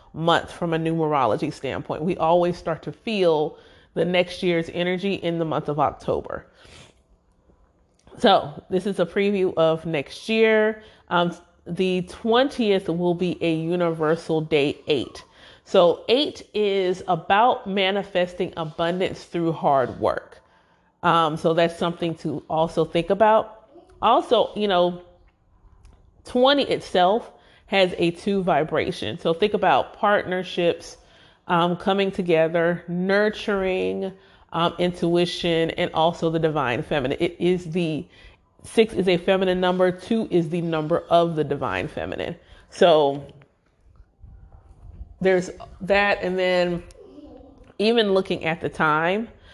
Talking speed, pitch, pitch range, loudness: 125 wpm, 175 Hz, 160-190 Hz, -22 LUFS